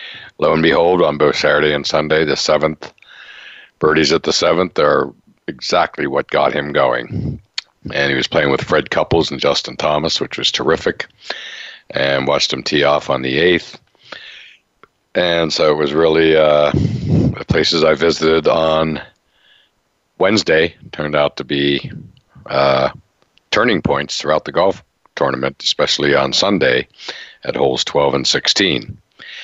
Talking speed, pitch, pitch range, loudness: 145 wpm, 75 Hz, 70-80 Hz, -15 LUFS